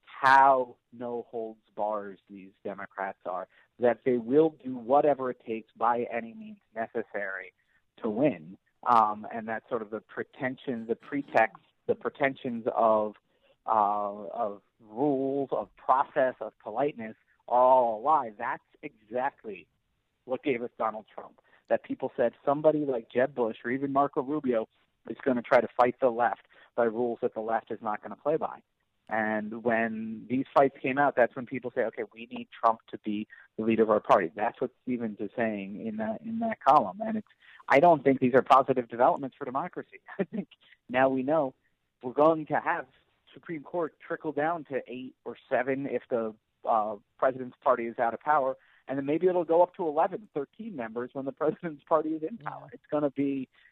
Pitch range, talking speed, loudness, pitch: 115-150 Hz, 190 wpm, -29 LUFS, 130 Hz